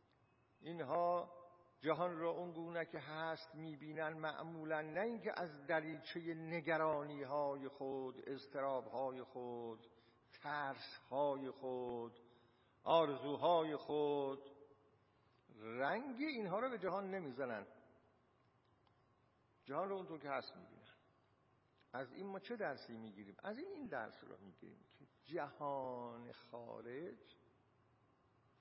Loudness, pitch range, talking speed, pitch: -44 LUFS, 125-160 Hz, 105 wpm, 140 Hz